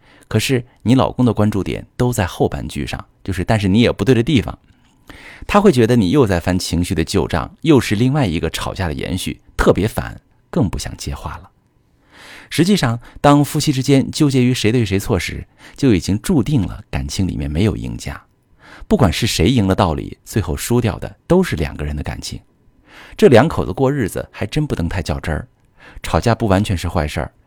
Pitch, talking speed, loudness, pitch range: 105 Hz, 295 characters per minute, -17 LUFS, 90-130 Hz